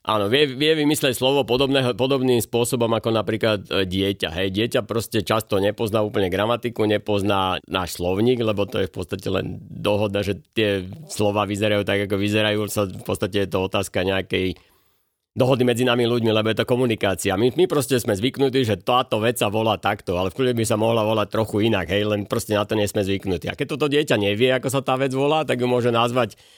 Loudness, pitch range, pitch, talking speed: -21 LUFS, 100-125 Hz, 110 Hz, 205 wpm